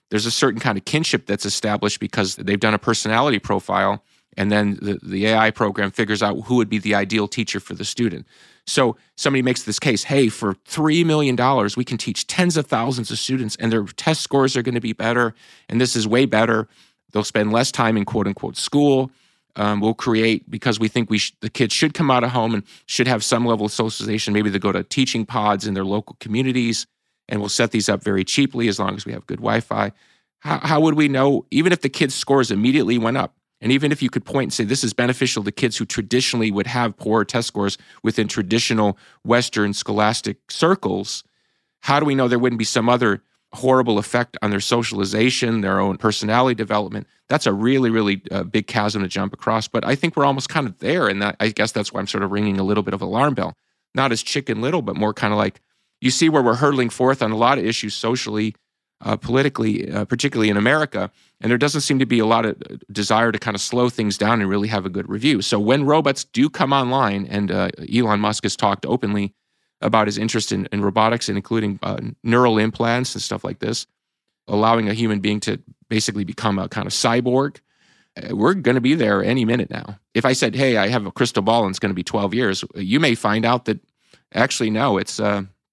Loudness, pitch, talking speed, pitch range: -20 LUFS, 110 Hz, 230 wpm, 105-125 Hz